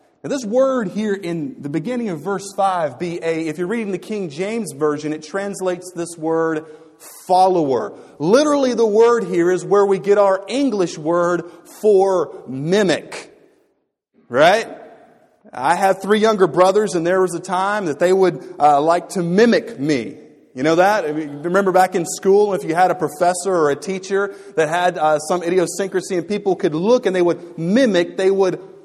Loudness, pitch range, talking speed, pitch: -18 LUFS, 170-200 Hz, 175 wpm, 185 Hz